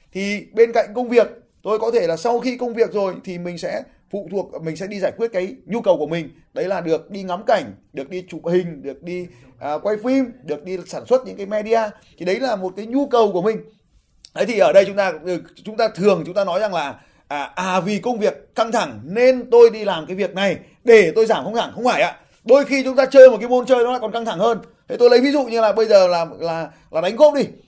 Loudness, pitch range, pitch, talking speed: -18 LUFS, 180-240 Hz, 205 Hz, 275 wpm